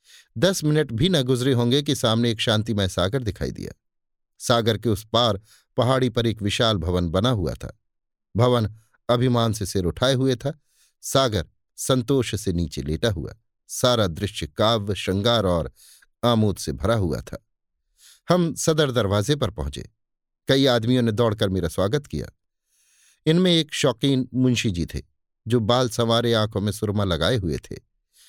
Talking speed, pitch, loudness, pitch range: 160 wpm, 115 Hz, -22 LUFS, 100-130 Hz